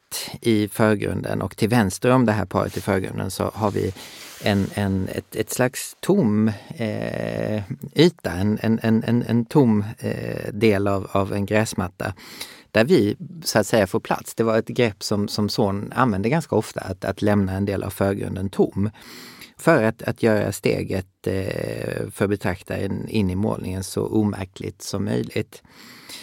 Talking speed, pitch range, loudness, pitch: 165 wpm, 100-110 Hz, -22 LUFS, 105 Hz